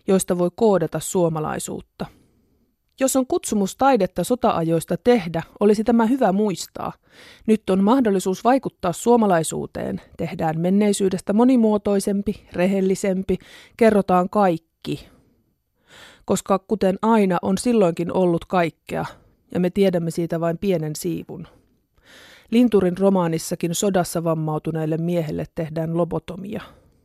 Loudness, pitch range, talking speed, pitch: -21 LUFS, 170-210 Hz, 100 wpm, 190 Hz